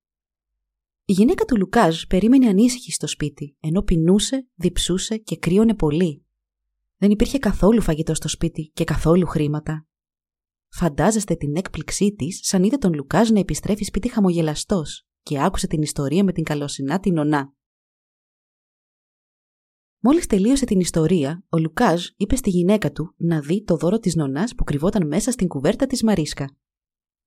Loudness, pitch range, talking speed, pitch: -20 LUFS, 150-205 Hz, 145 wpm, 170 Hz